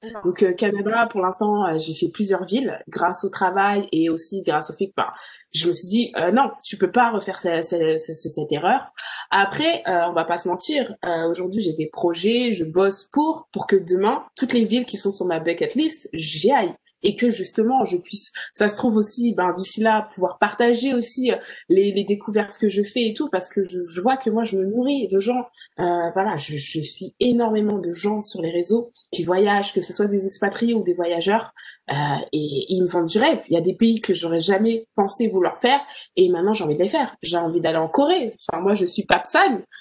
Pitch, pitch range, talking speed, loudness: 200 Hz, 175-230 Hz, 235 wpm, -21 LUFS